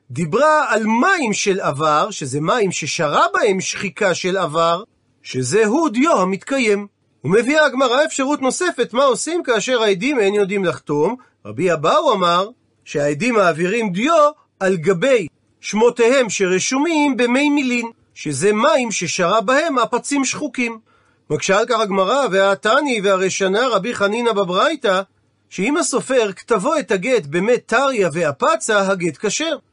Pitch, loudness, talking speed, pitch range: 215 Hz, -17 LUFS, 125 wpm, 185-260 Hz